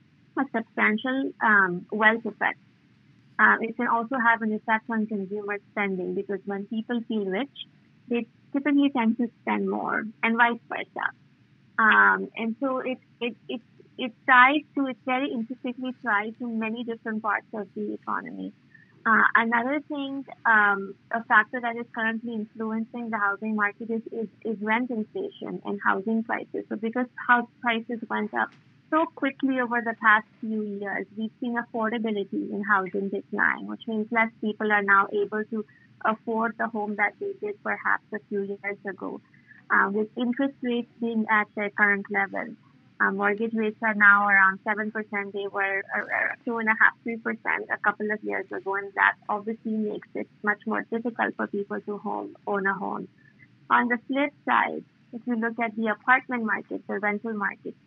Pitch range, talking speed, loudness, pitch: 205-240 Hz, 170 wpm, -25 LUFS, 220 Hz